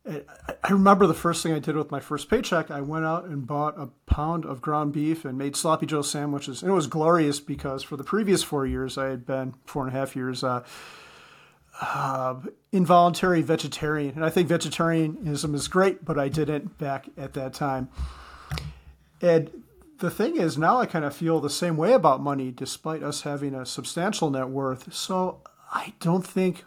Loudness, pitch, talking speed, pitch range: -25 LUFS, 150 Hz, 195 wpm, 135-170 Hz